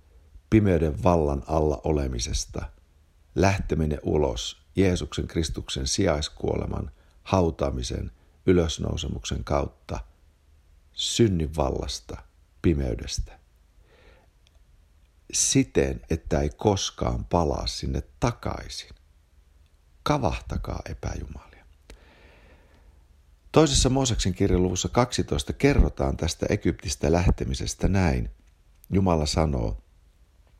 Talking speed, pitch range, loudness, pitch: 70 wpm, 70-90 Hz, -26 LUFS, 75 Hz